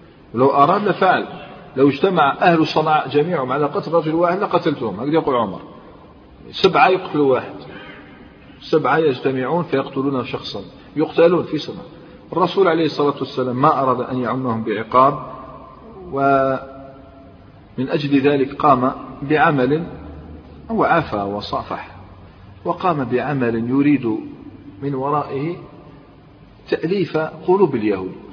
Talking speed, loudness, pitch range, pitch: 105 wpm, -18 LUFS, 125-160 Hz, 140 Hz